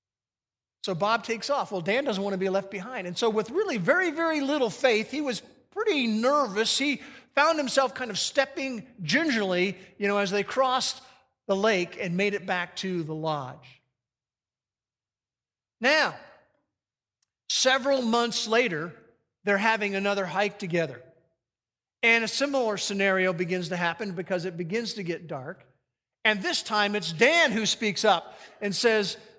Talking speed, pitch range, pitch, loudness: 155 wpm, 175-245 Hz, 205 Hz, -26 LUFS